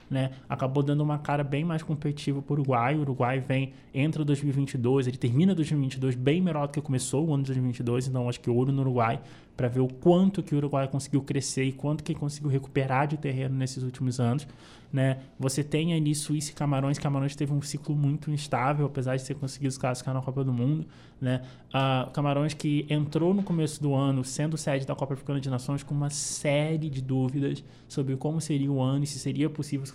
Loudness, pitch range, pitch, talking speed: -28 LUFS, 130-150 Hz, 140 Hz, 215 wpm